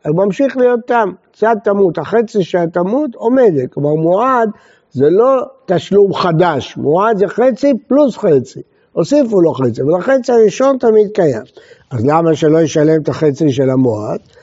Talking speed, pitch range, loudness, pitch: 150 wpm, 160-250 Hz, -13 LUFS, 200 Hz